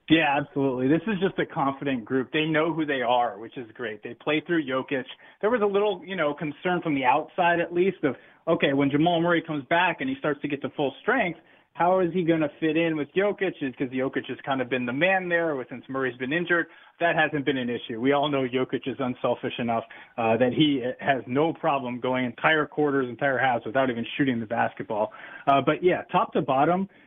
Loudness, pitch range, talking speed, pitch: -25 LUFS, 130-170 Hz, 230 wpm, 145 Hz